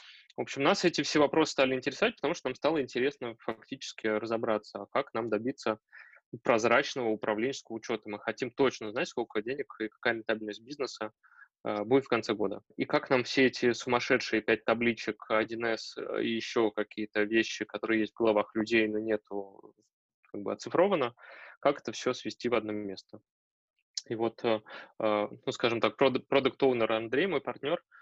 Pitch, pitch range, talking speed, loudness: 115 Hz, 110-125 Hz, 165 wpm, -31 LUFS